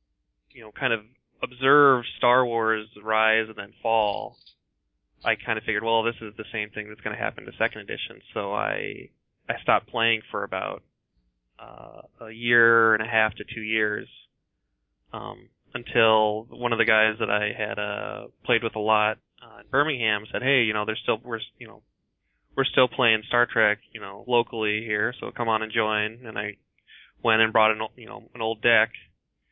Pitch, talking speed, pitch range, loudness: 110 Hz, 195 wpm, 105-115 Hz, -24 LUFS